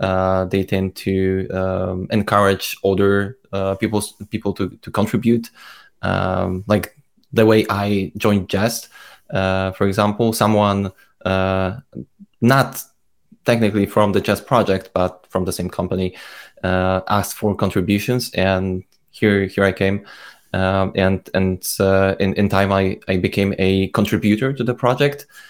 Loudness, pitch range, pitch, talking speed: -19 LUFS, 95-105 Hz, 100 Hz, 140 wpm